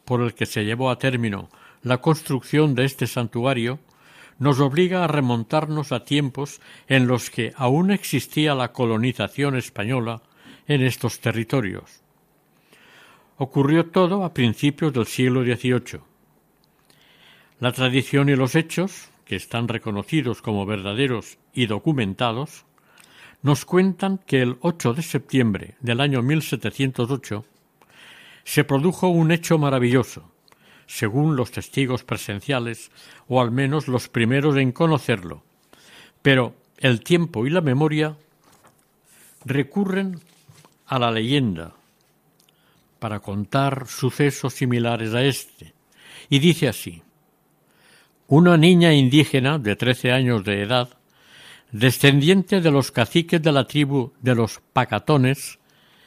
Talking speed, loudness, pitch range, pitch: 120 wpm, -21 LUFS, 120-150 Hz, 135 Hz